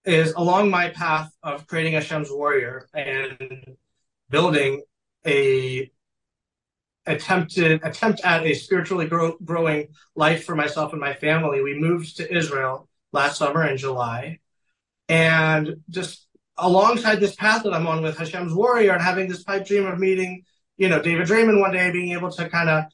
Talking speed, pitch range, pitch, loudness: 160 wpm, 150-180 Hz, 165 Hz, -21 LUFS